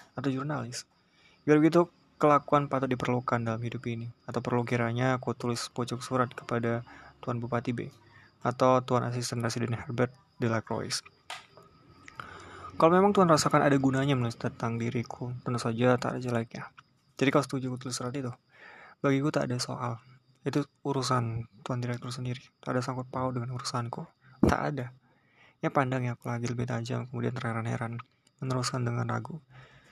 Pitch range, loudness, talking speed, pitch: 120-135 Hz, -30 LUFS, 155 wpm, 125 Hz